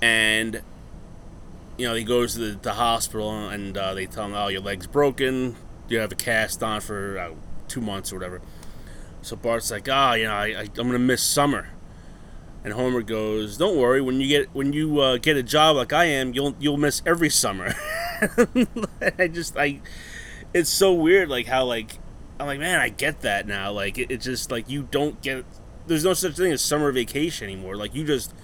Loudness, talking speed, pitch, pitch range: -23 LUFS, 200 wpm, 120 Hz, 105-145 Hz